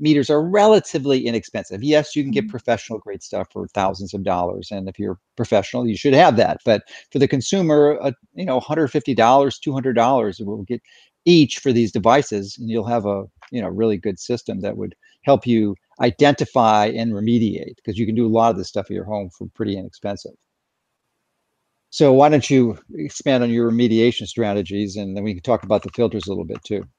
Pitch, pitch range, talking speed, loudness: 115 Hz, 105-135 Hz, 200 wpm, -19 LUFS